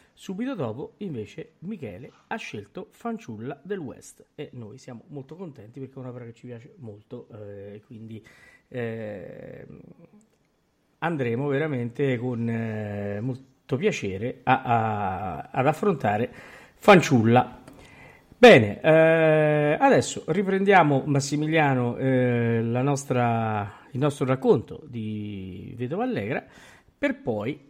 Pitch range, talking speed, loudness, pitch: 115-155 Hz, 115 wpm, -23 LUFS, 130 Hz